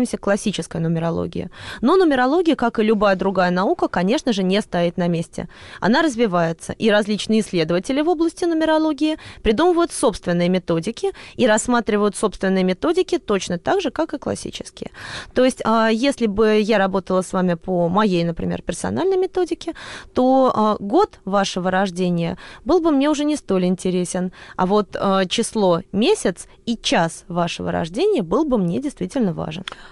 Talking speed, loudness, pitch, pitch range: 145 wpm, -19 LUFS, 215 Hz, 185-280 Hz